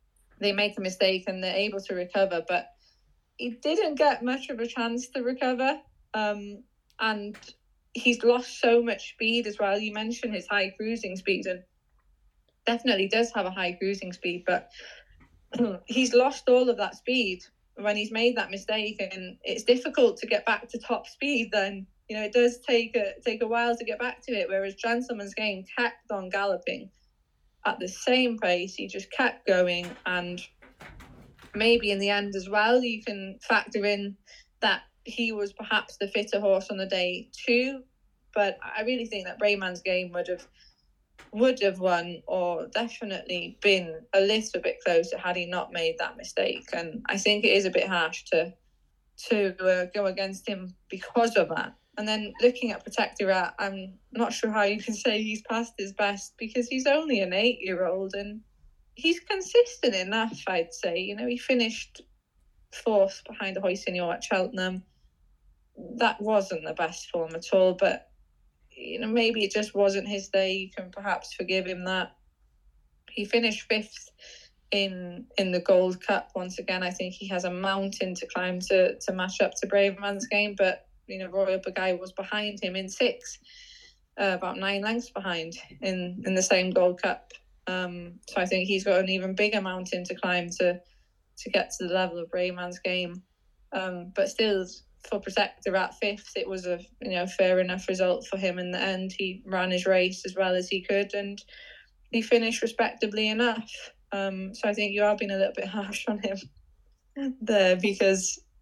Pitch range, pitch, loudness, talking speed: 185-230 Hz, 200 Hz, -27 LUFS, 185 wpm